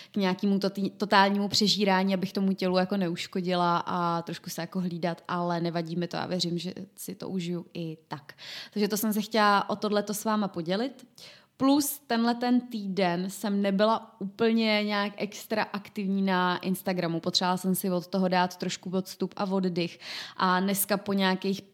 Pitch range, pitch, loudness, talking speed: 180-205 Hz, 190 Hz, -28 LUFS, 170 wpm